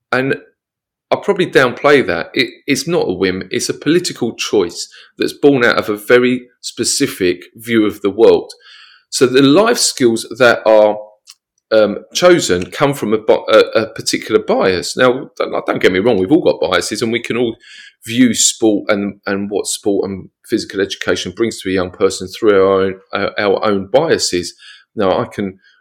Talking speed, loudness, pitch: 180 wpm, -14 LUFS, 115 Hz